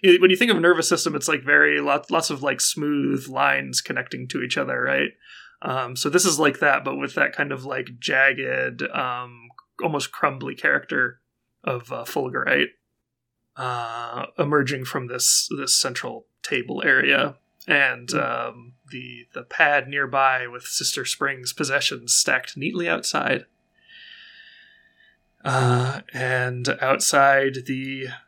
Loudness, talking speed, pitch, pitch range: -21 LUFS, 140 wpm, 135 Hz, 125-155 Hz